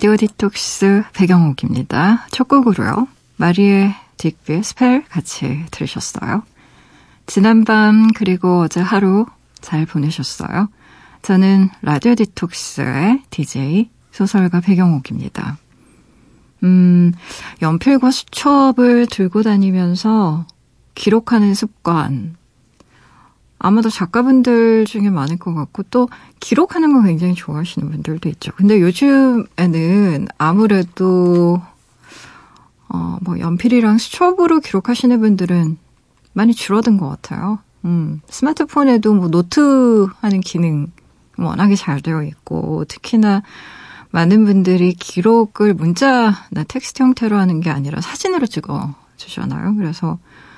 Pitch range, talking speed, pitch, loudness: 165-225 Hz, 255 characters per minute, 195 Hz, -15 LUFS